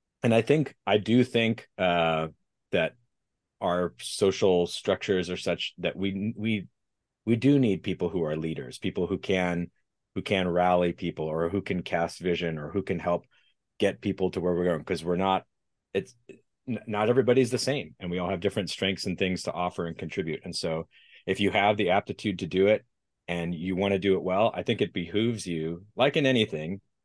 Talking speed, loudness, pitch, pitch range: 200 wpm, -28 LUFS, 95 Hz, 85-105 Hz